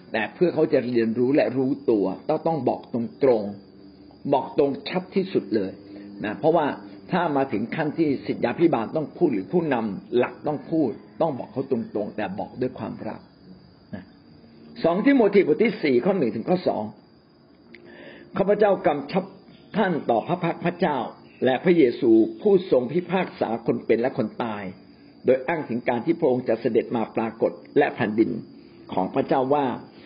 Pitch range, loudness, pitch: 110-180 Hz, -24 LUFS, 135 Hz